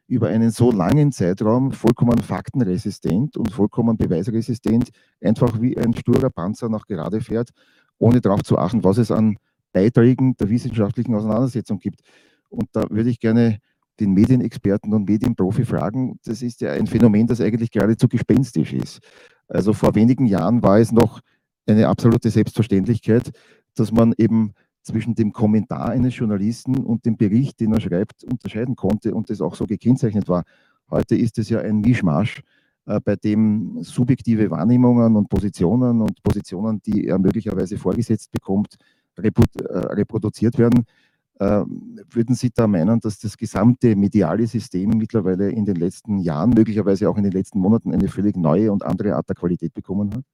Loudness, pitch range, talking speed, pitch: -19 LUFS, 105-120 Hz, 160 wpm, 110 Hz